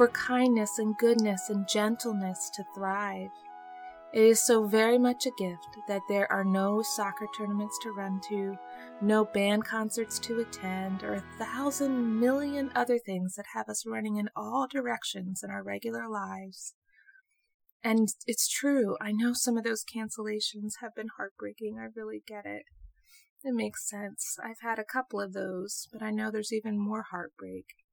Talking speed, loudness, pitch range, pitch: 170 wpm, -30 LUFS, 195-240 Hz, 215 Hz